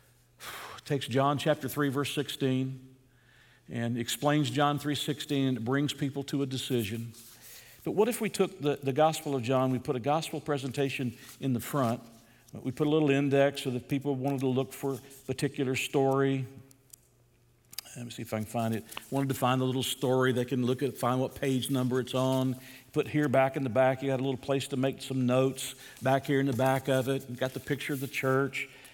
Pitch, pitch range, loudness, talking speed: 135 Hz, 130-140 Hz, -30 LUFS, 220 wpm